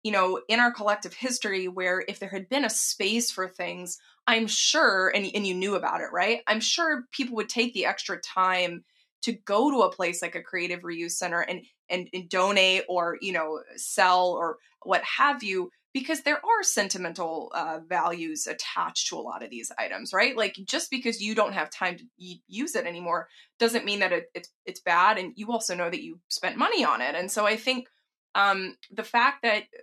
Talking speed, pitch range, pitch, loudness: 210 wpm, 180-230 Hz, 195 Hz, -26 LUFS